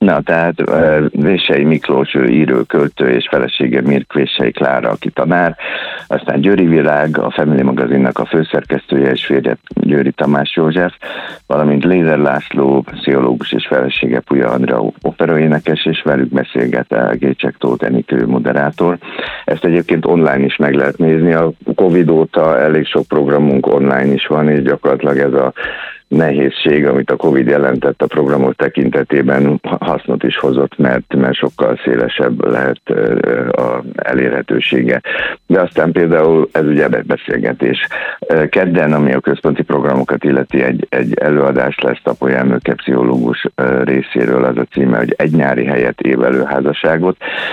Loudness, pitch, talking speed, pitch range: -13 LUFS, 70 Hz, 140 wpm, 65-80 Hz